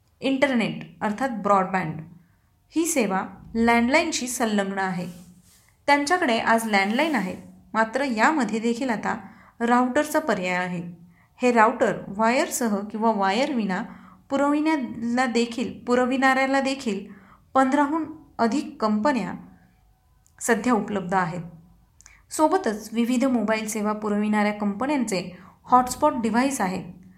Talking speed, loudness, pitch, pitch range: 95 wpm, -23 LUFS, 230 Hz, 195-265 Hz